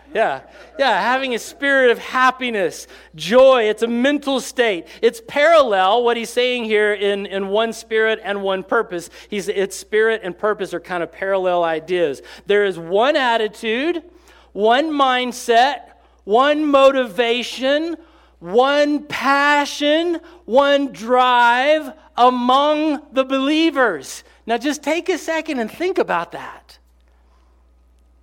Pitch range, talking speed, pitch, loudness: 200-285 Hz, 125 wpm, 240 Hz, -17 LUFS